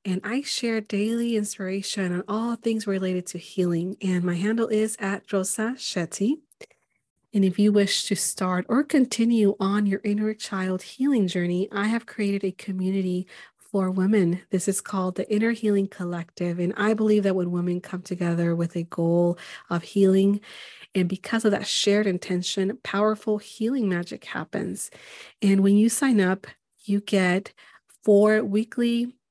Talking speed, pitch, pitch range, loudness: 160 wpm, 200 Hz, 185-215 Hz, -24 LUFS